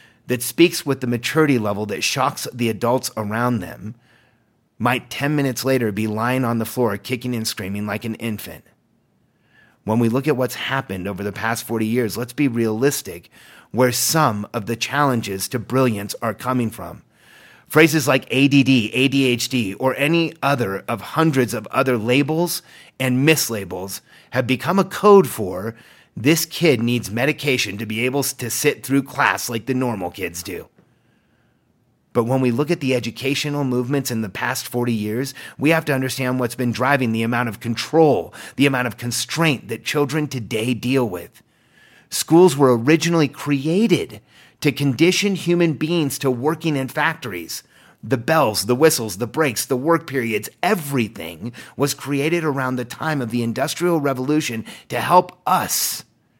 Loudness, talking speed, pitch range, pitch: -20 LUFS, 165 wpm, 115-145 Hz, 125 Hz